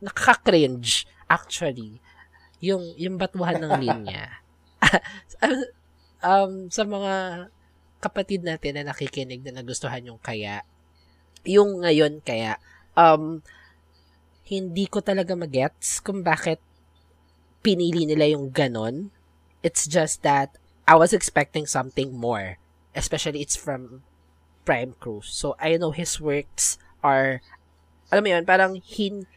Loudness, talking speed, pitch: -23 LUFS, 115 wpm, 145 Hz